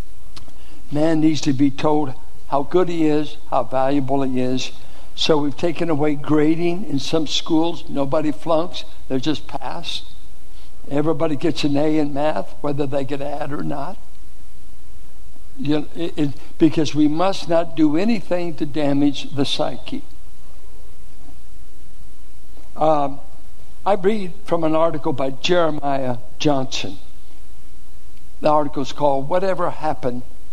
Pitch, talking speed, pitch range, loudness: 150 Hz, 130 wpm, 130-160 Hz, -21 LUFS